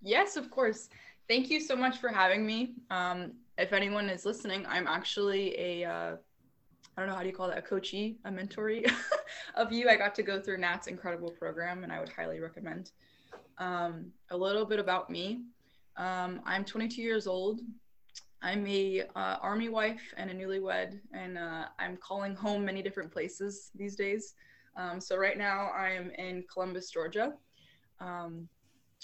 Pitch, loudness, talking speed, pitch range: 195 Hz, -34 LUFS, 175 wpm, 180-220 Hz